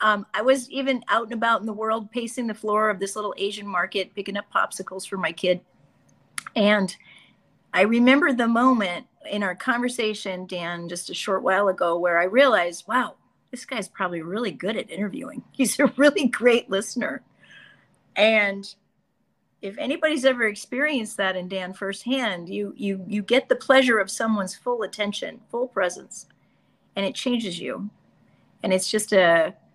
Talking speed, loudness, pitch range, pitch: 165 wpm, -23 LUFS, 190-245 Hz, 210 Hz